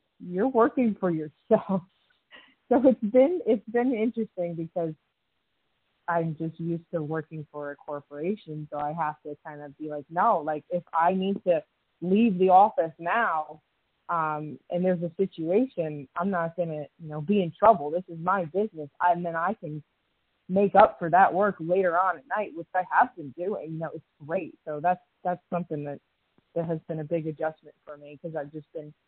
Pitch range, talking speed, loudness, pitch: 155-195 Hz, 195 wpm, -27 LUFS, 170 Hz